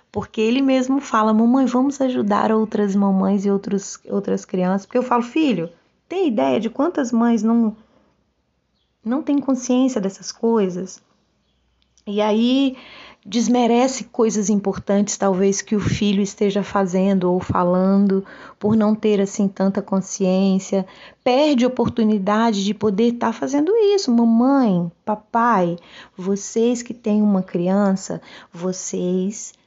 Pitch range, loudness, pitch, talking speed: 195-240 Hz, -19 LUFS, 215 Hz, 125 wpm